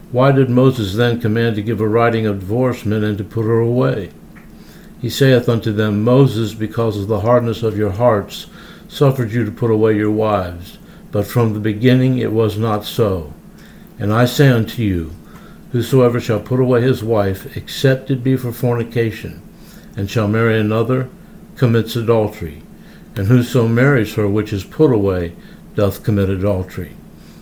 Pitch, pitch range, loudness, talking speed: 115 Hz, 105-125 Hz, -16 LUFS, 165 wpm